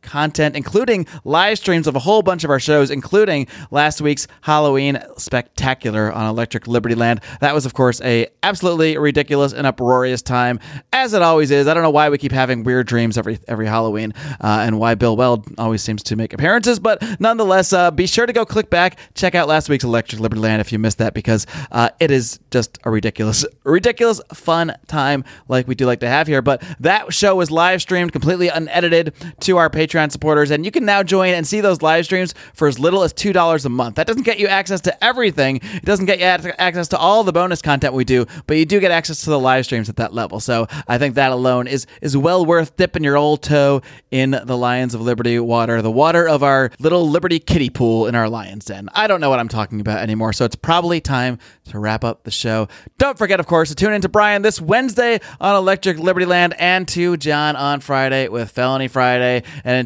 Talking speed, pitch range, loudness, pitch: 225 wpm, 120-175 Hz, -16 LUFS, 145 Hz